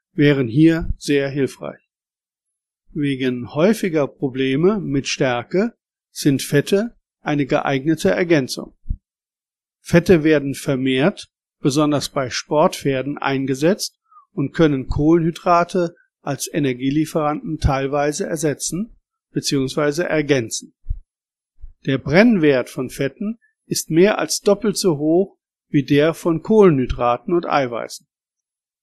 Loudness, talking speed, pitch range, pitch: -19 LUFS, 95 wpm, 140-180 Hz, 150 Hz